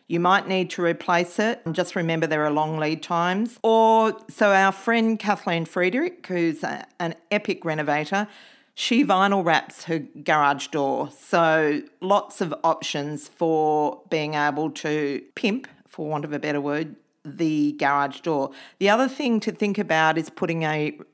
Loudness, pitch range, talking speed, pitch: -23 LUFS, 155-200 Hz, 165 wpm, 165 Hz